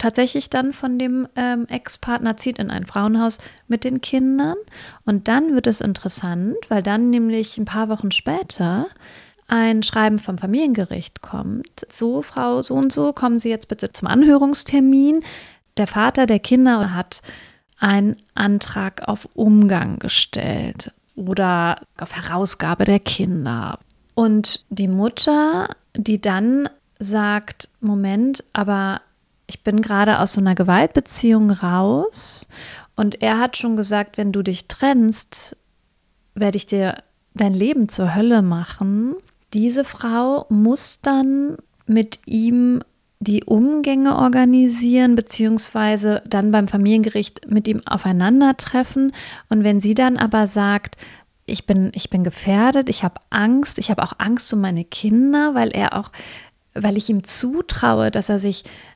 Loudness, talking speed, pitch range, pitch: -18 LUFS, 140 wpm, 205-250 Hz, 220 Hz